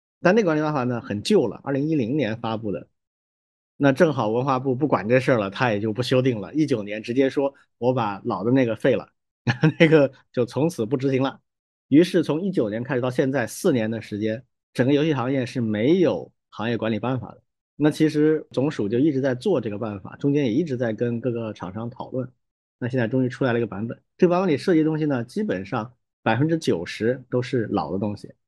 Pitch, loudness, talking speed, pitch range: 125 Hz, -23 LUFS, 330 characters per minute, 110-140 Hz